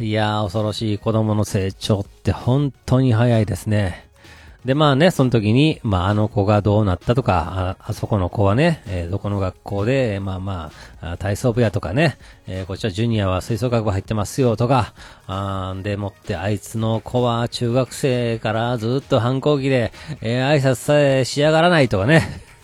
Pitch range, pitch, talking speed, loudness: 100-125 Hz, 110 Hz, 340 characters per minute, -19 LUFS